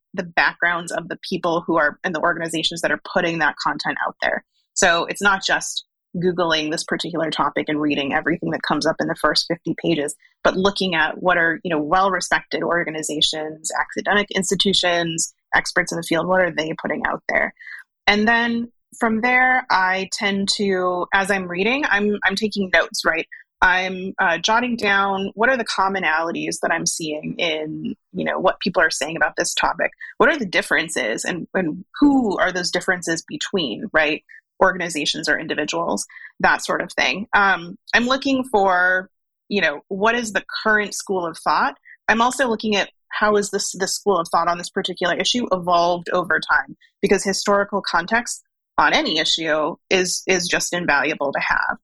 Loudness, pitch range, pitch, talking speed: -20 LUFS, 165-200 Hz, 185 Hz, 180 wpm